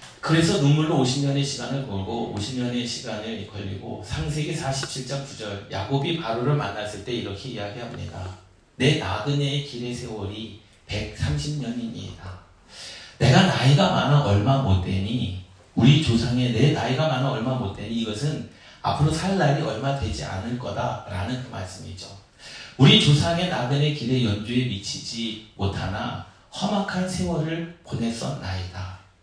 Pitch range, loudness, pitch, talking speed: 100-140 Hz, -24 LUFS, 120 Hz, 295 characters per minute